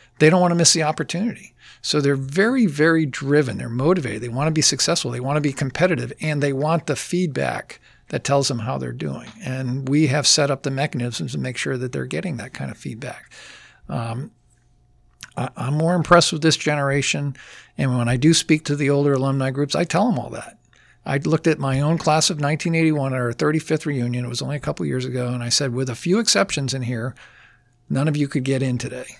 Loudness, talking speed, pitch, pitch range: -20 LUFS, 225 wpm, 145 Hz, 130-155 Hz